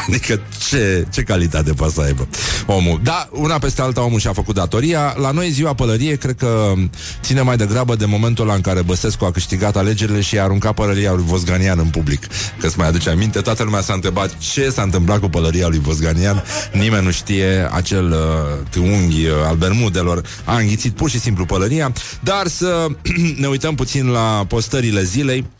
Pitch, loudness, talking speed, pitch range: 105 Hz, -17 LUFS, 185 wpm, 90-120 Hz